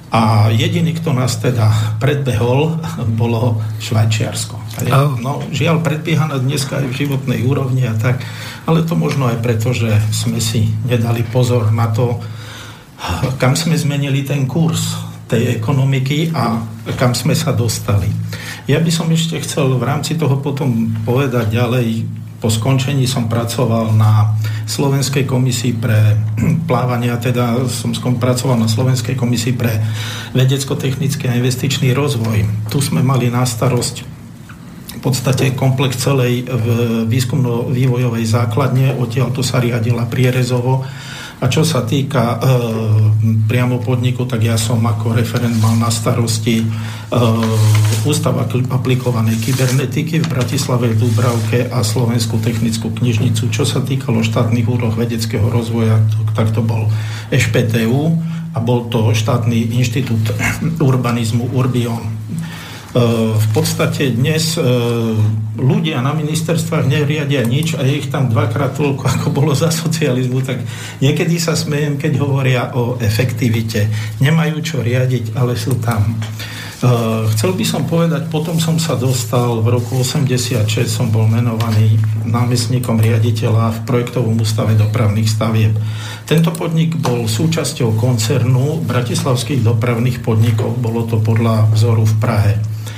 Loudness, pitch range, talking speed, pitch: -15 LUFS, 115-135 Hz, 130 wpm, 120 Hz